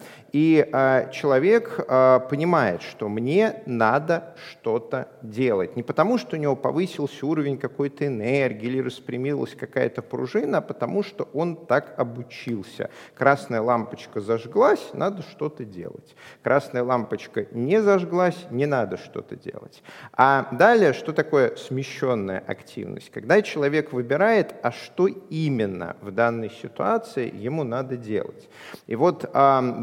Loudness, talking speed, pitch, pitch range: -23 LUFS, 130 wpm, 140 Hz, 125-165 Hz